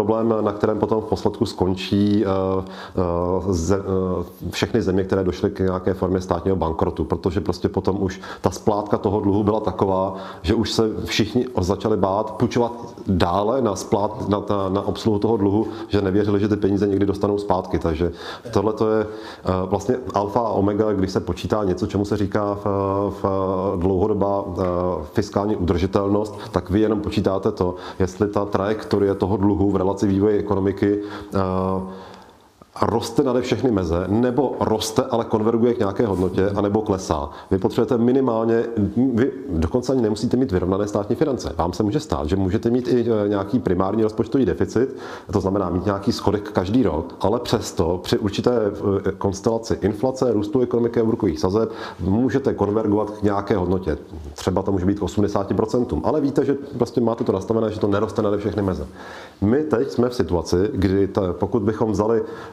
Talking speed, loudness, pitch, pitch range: 170 wpm, -21 LUFS, 100 Hz, 95-110 Hz